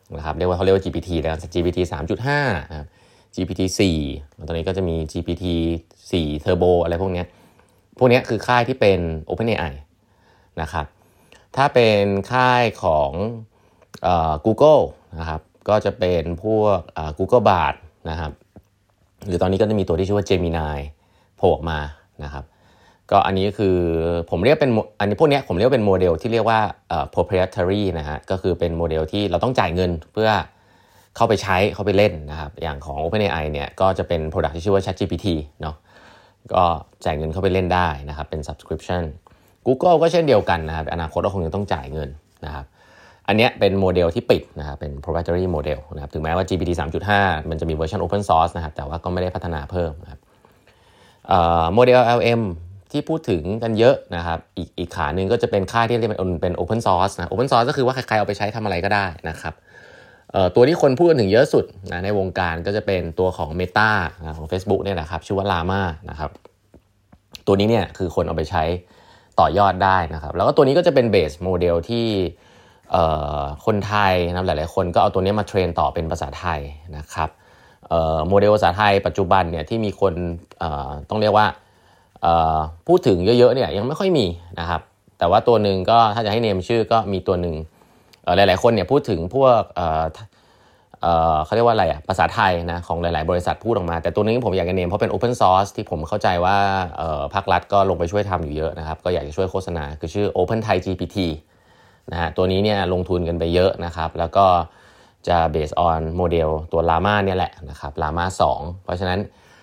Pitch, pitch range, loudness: 90 Hz, 85-100 Hz, -20 LUFS